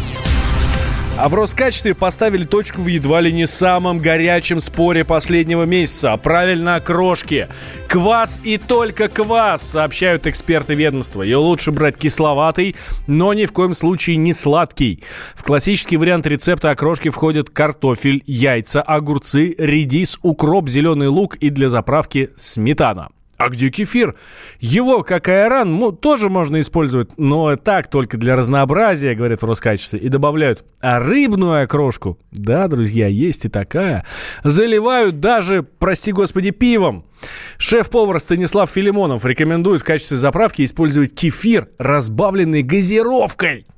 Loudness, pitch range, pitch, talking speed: -15 LUFS, 140-185 Hz, 160 Hz, 130 wpm